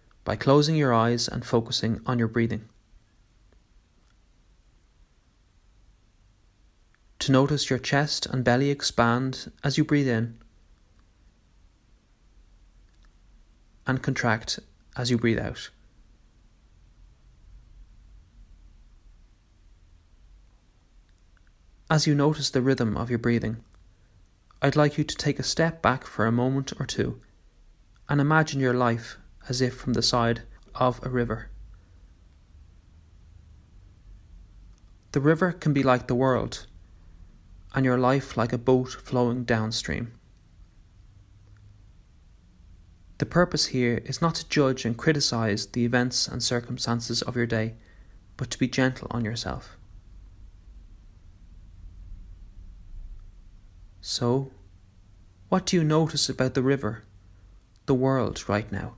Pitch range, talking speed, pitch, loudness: 90-125 Hz, 110 wpm, 105 Hz, -25 LUFS